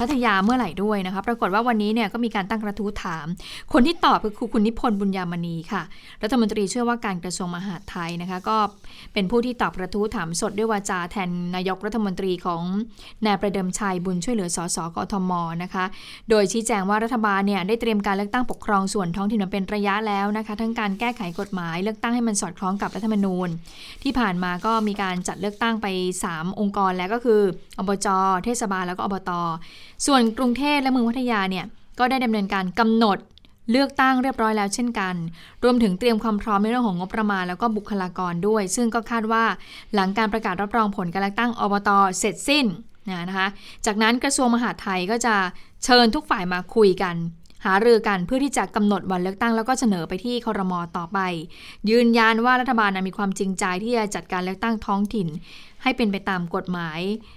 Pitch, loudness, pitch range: 205 Hz, -23 LUFS, 190-230 Hz